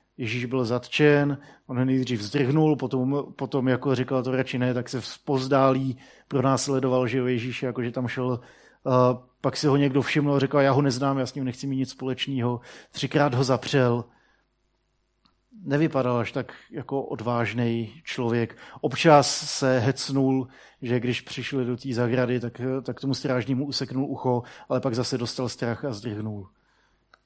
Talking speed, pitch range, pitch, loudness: 160 wpm, 125-135 Hz, 130 Hz, -25 LUFS